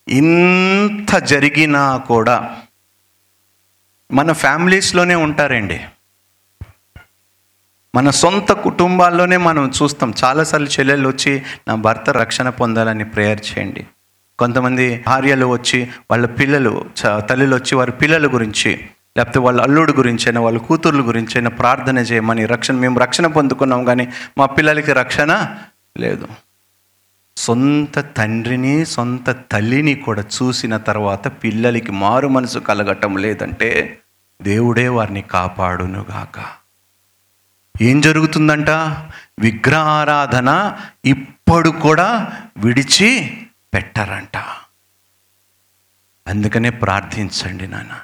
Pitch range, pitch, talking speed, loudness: 100-140 Hz, 125 Hz, 95 wpm, -15 LUFS